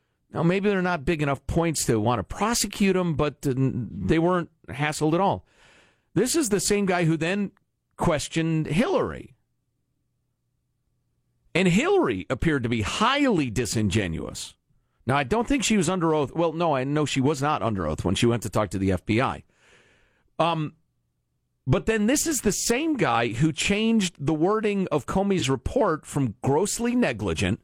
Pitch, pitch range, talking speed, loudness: 155 Hz, 120-190 Hz, 165 wpm, -24 LUFS